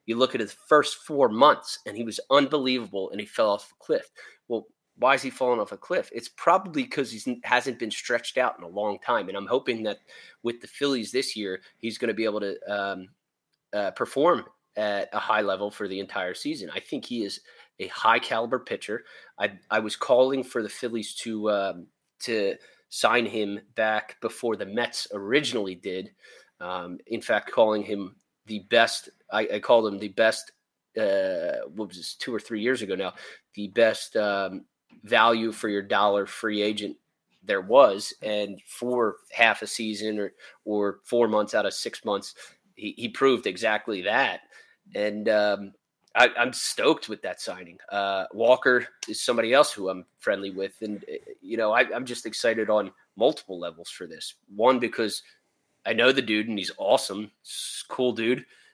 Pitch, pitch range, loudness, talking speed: 110 Hz, 100-125 Hz, -26 LUFS, 185 wpm